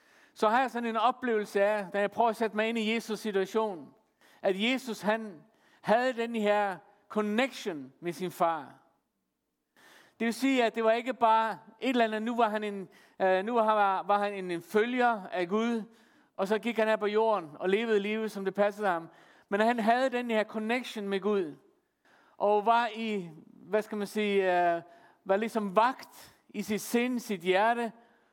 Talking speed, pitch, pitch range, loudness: 185 wpm, 215 Hz, 200-230 Hz, -29 LUFS